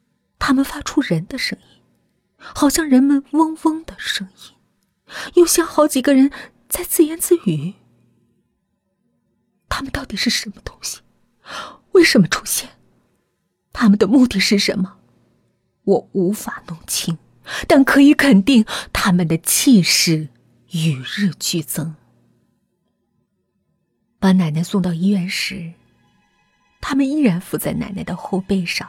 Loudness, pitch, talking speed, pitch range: -17 LUFS, 205 Hz, 185 characters per minute, 180-280 Hz